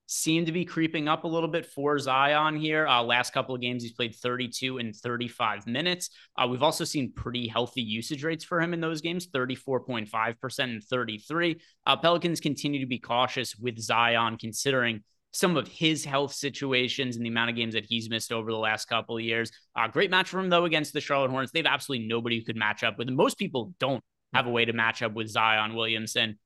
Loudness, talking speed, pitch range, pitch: -28 LUFS, 220 wpm, 115-150 Hz, 125 Hz